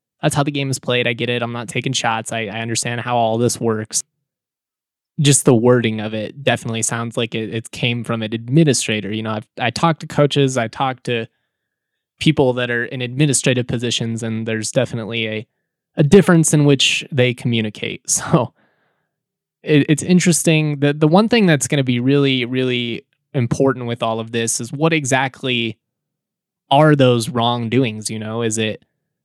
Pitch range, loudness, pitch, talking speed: 115-145 Hz, -17 LUFS, 125 Hz, 185 wpm